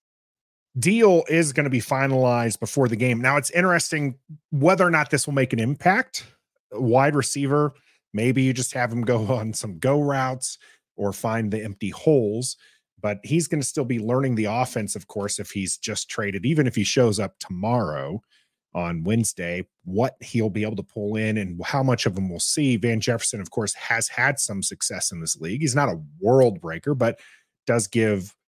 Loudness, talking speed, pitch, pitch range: -23 LUFS, 195 wpm, 125 Hz, 105-145 Hz